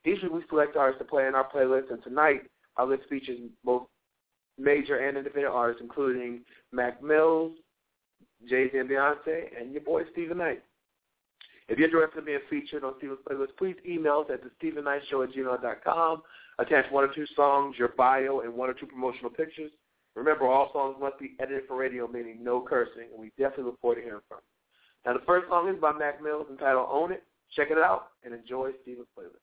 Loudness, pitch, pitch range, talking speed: -28 LUFS, 135 Hz, 125-155 Hz, 200 wpm